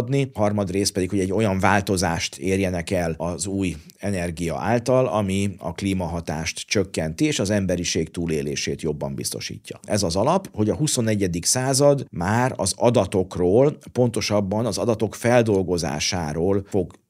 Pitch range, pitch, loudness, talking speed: 85-110 Hz, 100 Hz, -22 LUFS, 135 wpm